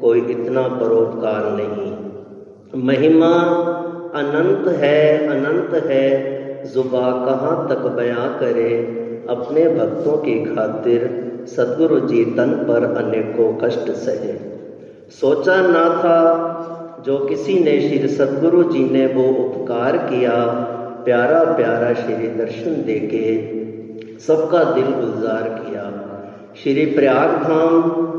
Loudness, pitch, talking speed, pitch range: -17 LUFS, 135 Hz, 105 wpm, 120-165 Hz